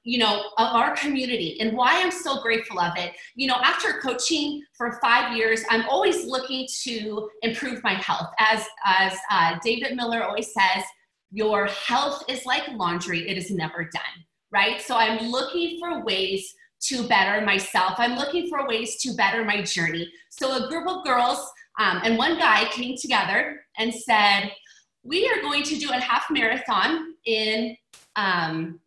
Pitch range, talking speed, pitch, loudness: 200-265 Hz, 170 wpm, 230 Hz, -23 LUFS